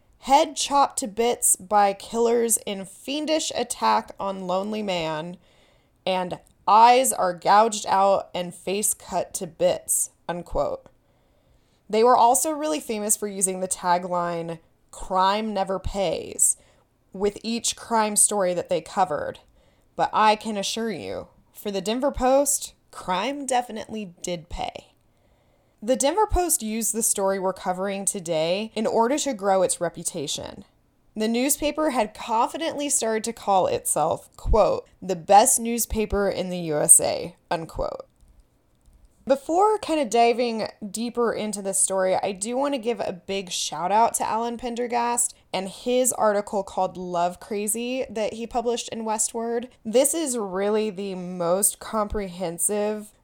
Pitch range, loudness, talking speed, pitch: 190-240 Hz, -23 LUFS, 140 wpm, 215 Hz